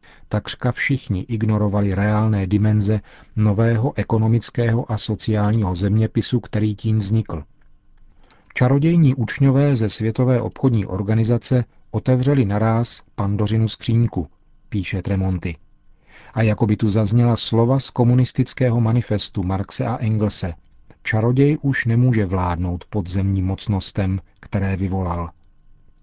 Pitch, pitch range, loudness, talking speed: 110 Hz, 100-120 Hz, -20 LUFS, 105 wpm